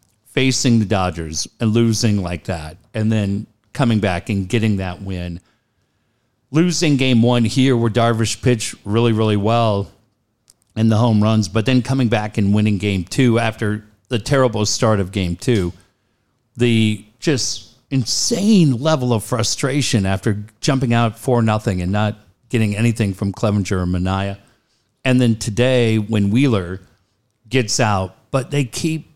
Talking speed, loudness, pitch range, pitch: 150 wpm, -18 LUFS, 105-120 Hz, 110 Hz